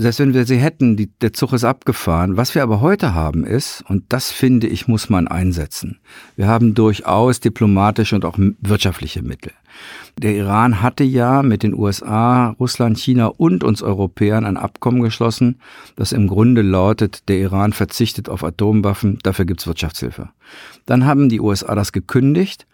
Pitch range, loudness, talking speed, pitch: 100-120 Hz, -16 LUFS, 175 wpm, 110 Hz